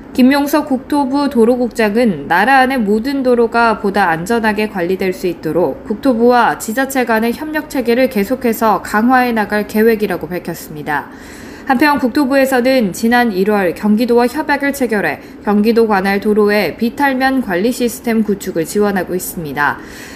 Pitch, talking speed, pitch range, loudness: 230 Hz, 340 characters per minute, 205-260 Hz, -14 LUFS